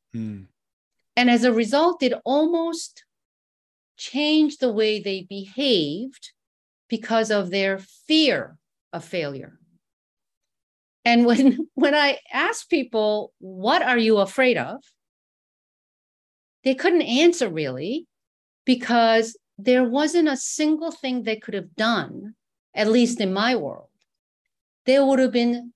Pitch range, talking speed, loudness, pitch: 220-290 Hz, 120 wpm, -21 LUFS, 245 Hz